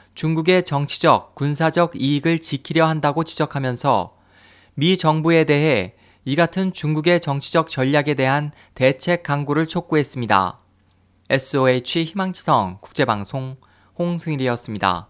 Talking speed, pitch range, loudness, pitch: 290 characters per minute, 125-160 Hz, -19 LUFS, 145 Hz